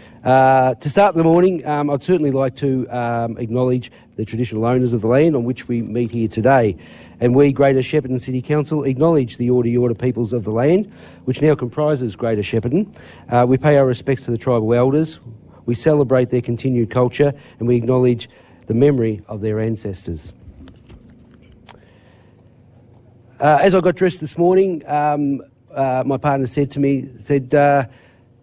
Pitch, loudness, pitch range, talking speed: 125 Hz, -17 LUFS, 120-145 Hz, 170 wpm